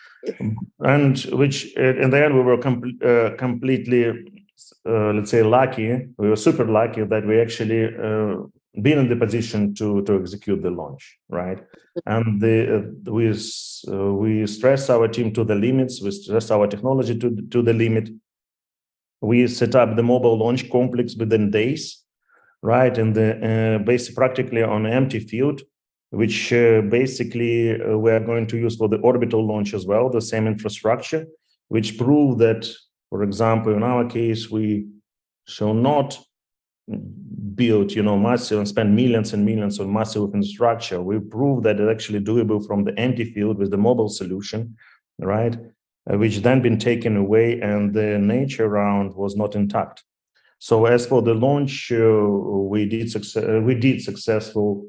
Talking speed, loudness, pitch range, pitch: 165 wpm, -20 LUFS, 105-120 Hz, 115 Hz